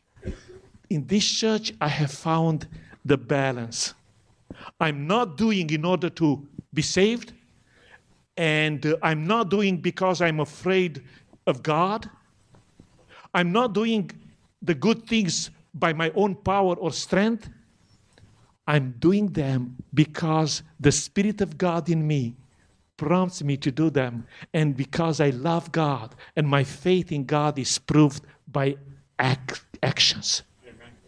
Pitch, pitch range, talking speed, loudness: 155 Hz, 140-180 Hz, 130 wpm, -24 LUFS